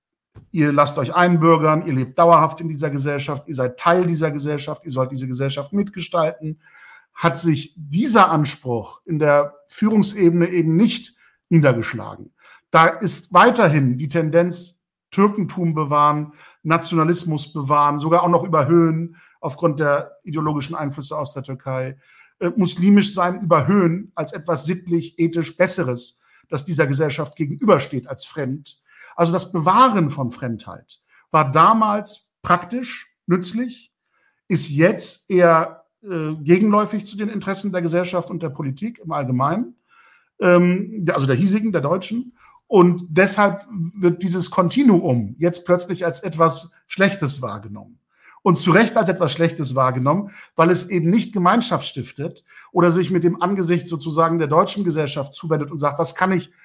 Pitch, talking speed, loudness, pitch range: 170 Hz, 140 wpm, -19 LUFS, 150-185 Hz